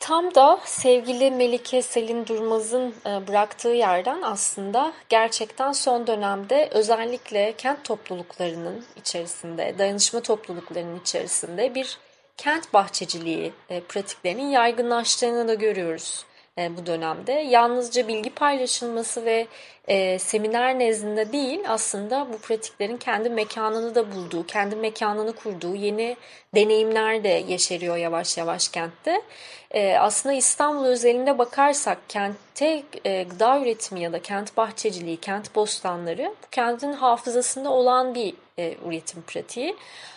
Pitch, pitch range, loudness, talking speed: 225 Hz, 195-250 Hz, -23 LUFS, 110 wpm